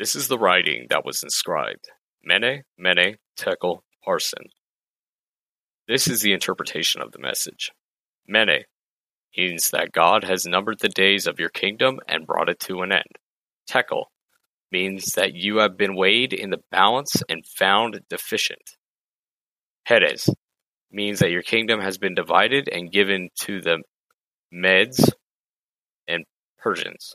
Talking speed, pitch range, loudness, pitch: 140 wpm, 90-105 Hz, -21 LUFS, 95 Hz